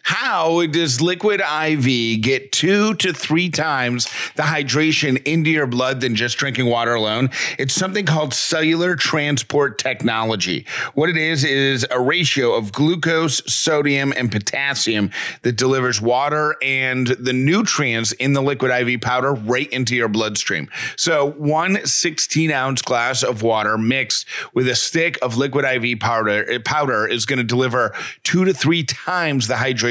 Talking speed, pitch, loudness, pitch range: 155 wpm, 135 Hz, -18 LUFS, 125-155 Hz